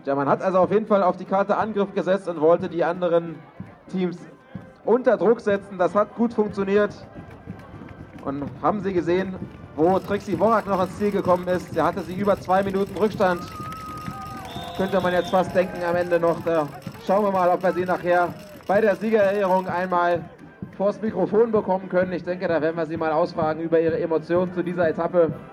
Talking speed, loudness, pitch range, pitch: 190 wpm, -22 LUFS, 170-195 Hz, 180 Hz